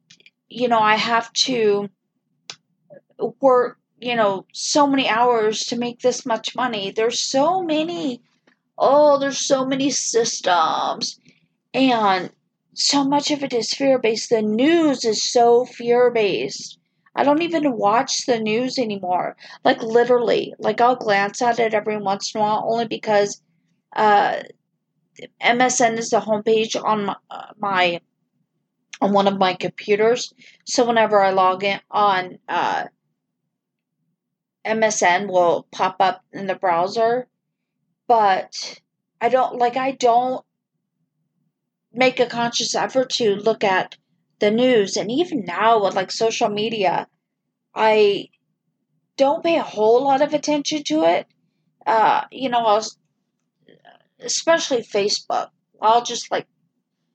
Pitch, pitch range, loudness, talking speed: 230 Hz, 205-255 Hz, -19 LUFS, 130 wpm